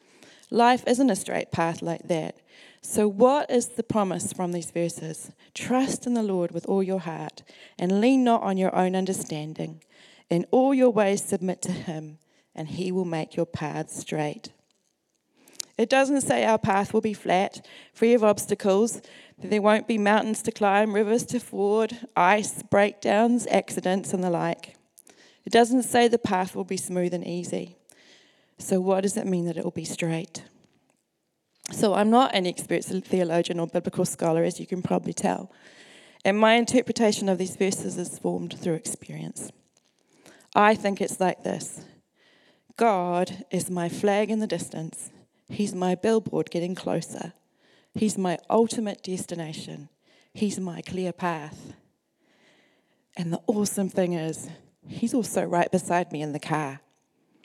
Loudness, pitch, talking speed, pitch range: -25 LUFS, 190 Hz, 160 wpm, 170-220 Hz